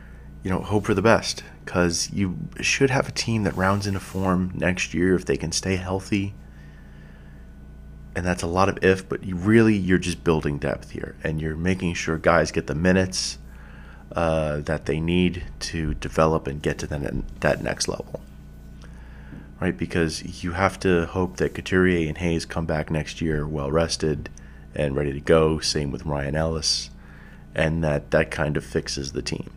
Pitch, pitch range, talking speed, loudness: 80 Hz, 70-90 Hz, 185 wpm, -24 LUFS